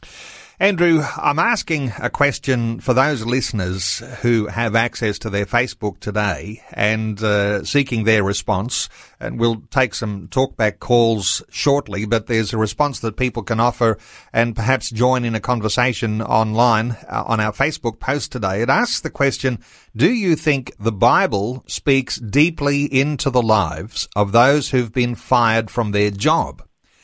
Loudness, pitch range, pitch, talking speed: -19 LUFS, 110-130 Hz, 115 Hz, 155 wpm